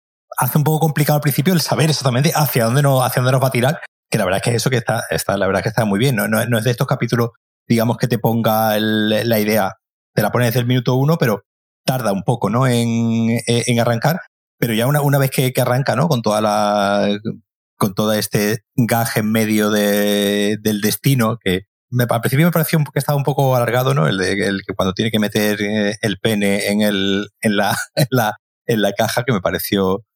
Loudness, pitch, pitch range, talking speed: -17 LUFS, 115 Hz, 105-130 Hz, 235 wpm